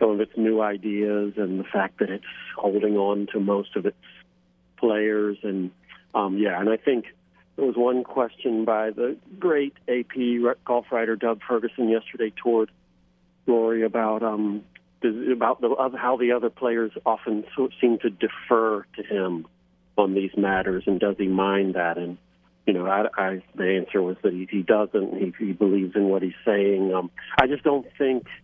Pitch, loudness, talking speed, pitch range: 105 Hz, -24 LUFS, 180 wpm, 95-115 Hz